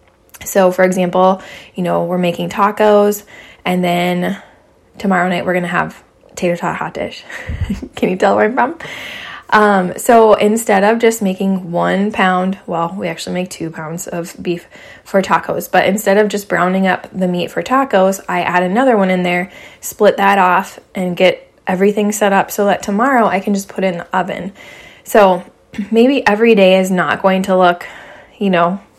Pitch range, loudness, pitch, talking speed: 180-205 Hz, -14 LUFS, 190 Hz, 185 wpm